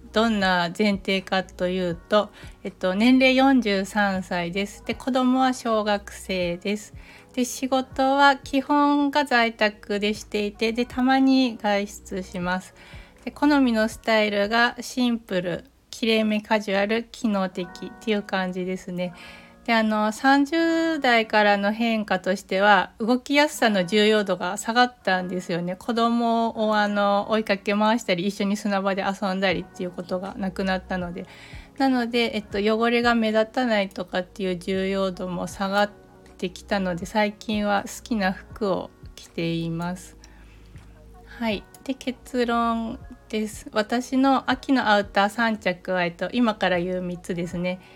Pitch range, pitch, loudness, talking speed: 185-235 Hz, 210 Hz, -23 LUFS, 280 characters per minute